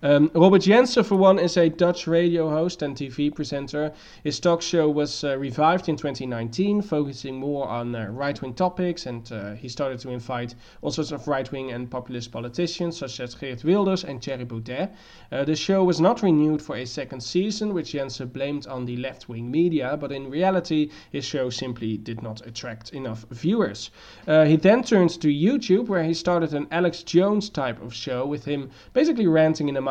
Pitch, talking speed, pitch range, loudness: 150 Hz, 200 wpm, 130-175 Hz, -23 LUFS